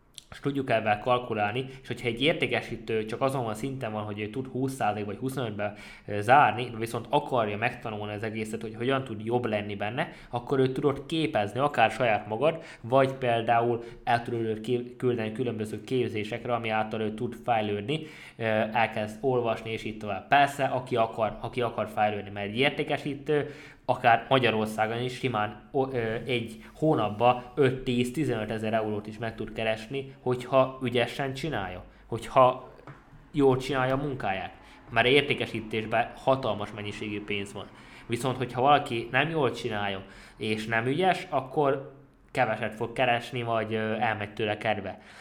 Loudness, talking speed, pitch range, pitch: -28 LUFS, 145 wpm, 110-130 Hz, 120 Hz